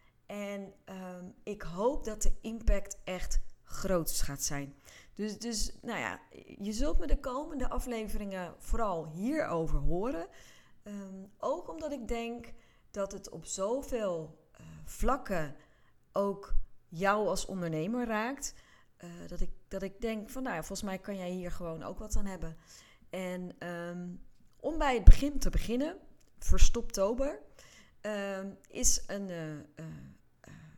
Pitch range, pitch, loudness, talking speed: 175-230 Hz, 195 Hz, -35 LUFS, 140 wpm